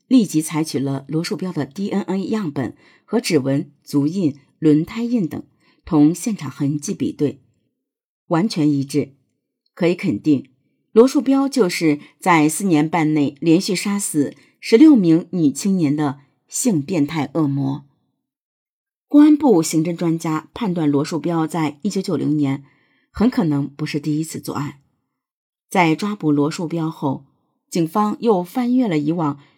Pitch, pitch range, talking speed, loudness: 160 Hz, 145-200 Hz, 220 characters per minute, -19 LUFS